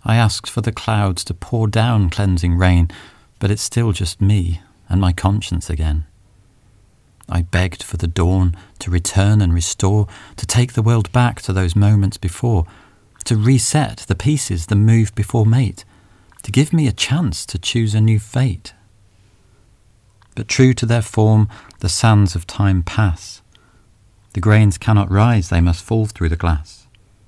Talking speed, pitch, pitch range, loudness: 165 wpm, 100 Hz, 95-110 Hz, -17 LUFS